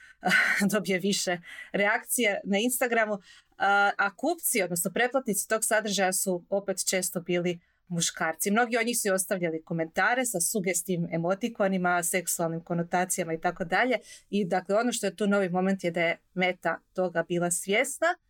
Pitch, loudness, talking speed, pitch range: 190 Hz, -27 LUFS, 150 wpm, 175-210 Hz